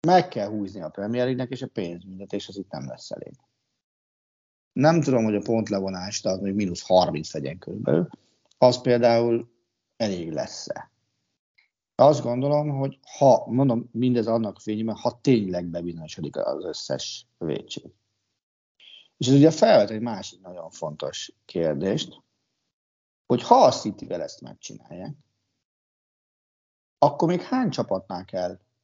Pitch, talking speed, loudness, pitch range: 115 Hz, 135 wpm, -24 LUFS, 100-135 Hz